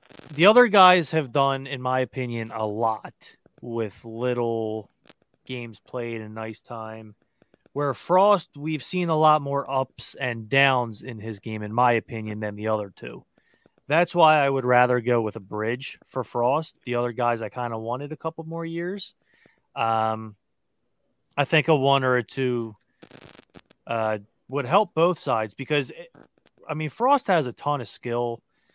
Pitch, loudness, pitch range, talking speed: 125 Hz, -24 LUFS, 115-155 Hz, 170 wpm